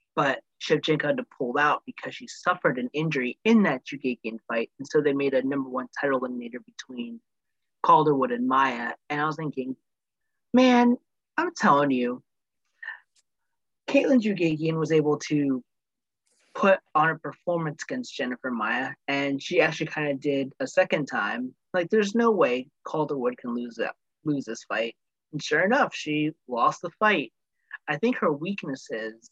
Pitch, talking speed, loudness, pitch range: 150 Hz, 160 wpm, -26 LUFS, 130-195 Hz